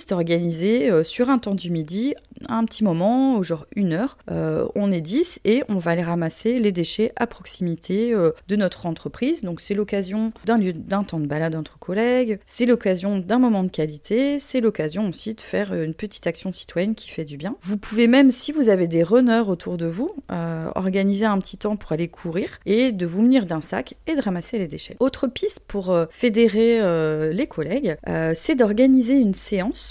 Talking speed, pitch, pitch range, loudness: 205 wpm, 205 Hz, 170-235 Hz, -22 LUFS